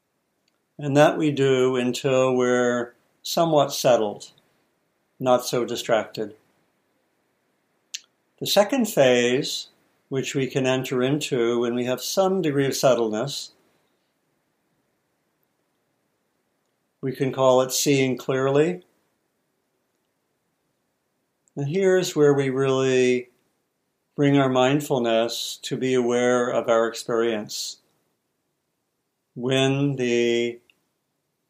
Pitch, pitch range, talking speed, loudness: 130 Hz, 120-140 Hz, 90 wpm, -22 LUFS